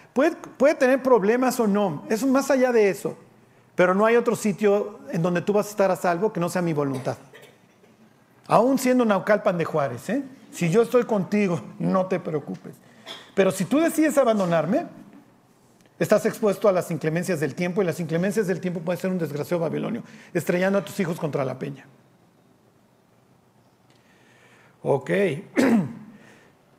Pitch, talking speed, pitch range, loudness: 195 Hz, 160 wpm, 175-230 Hz, -23 LUFS